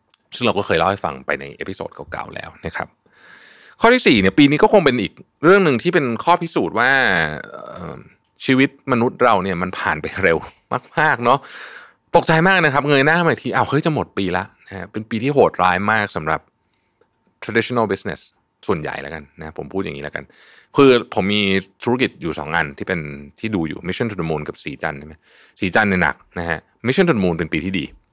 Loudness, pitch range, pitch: -18 LUFS, 90-140 Hz, 110 Hz